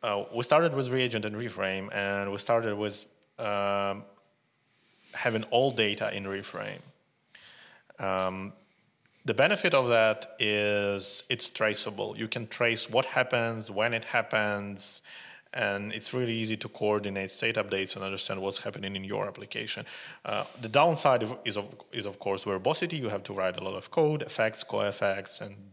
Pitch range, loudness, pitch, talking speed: 100-115 Hz, -29 LUFS, 105 Hz, 160 wpm